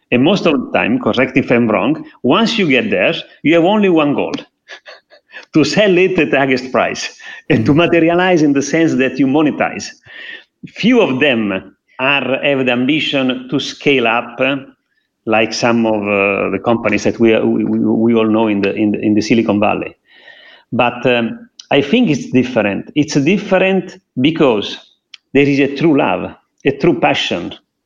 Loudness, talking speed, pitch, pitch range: -14 LUFS, 180 wpm, 135 Hz, 115-170 Hz